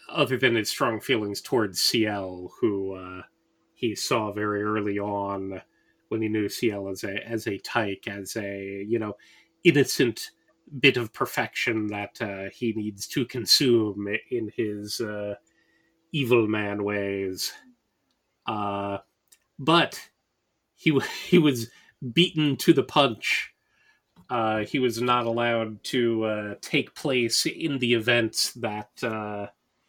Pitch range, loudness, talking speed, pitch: 100-120 Hz, -26 LUFS, 135 wpm, 110 Hz